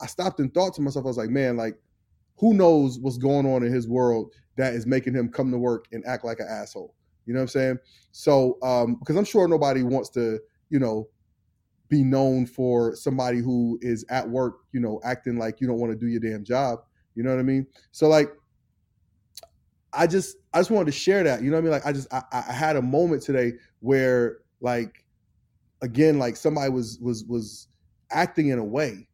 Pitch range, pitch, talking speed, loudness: 115-140 Hz, 125 Hz, 220 wpm, -24 LUFS